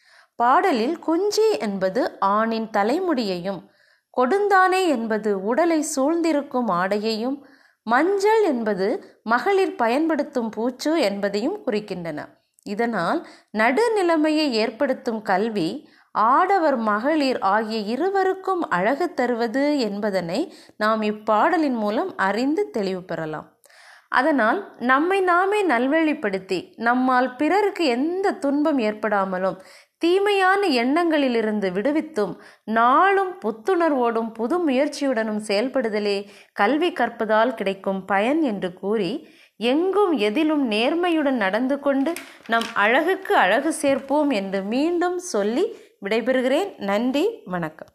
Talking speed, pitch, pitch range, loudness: 90 wpm, 265 Hz, 215-330 Hz, -21 LUFS